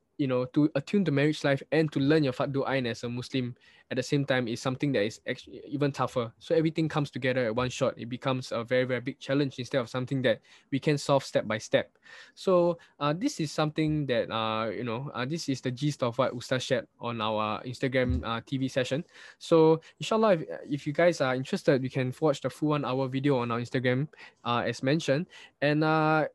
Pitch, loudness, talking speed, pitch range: 135 Hz, -29 LUFS, 225 wpm, 125-150 Hz